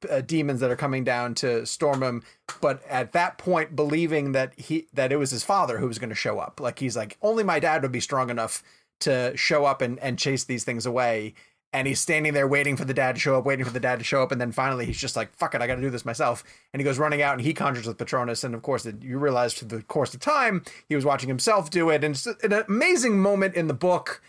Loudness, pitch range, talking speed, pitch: -25 LUFS, 125-155 Hz, 275 wpm, 135 Hz